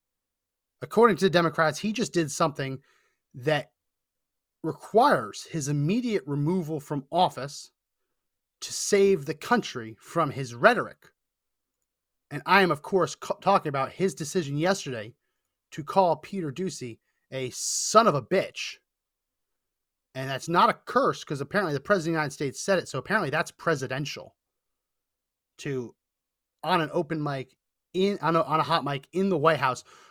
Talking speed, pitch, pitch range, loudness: 155 wpm, 160 Hz, 135-185 Hz, -26 LUFS